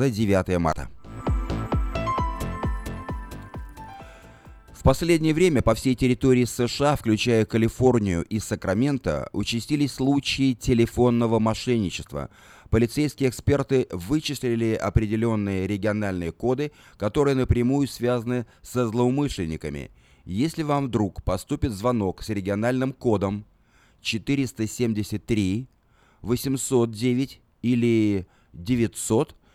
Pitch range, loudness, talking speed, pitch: 100-130 Hz, -24 LUFS, 80 wpm, 115 Hz